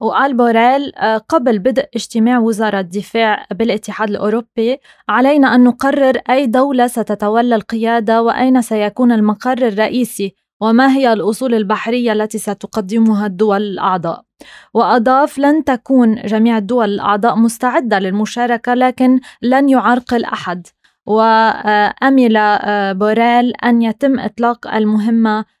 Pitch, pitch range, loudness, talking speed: 230 Hz, 215-250 Hz, -13 LUFS, 110 wpm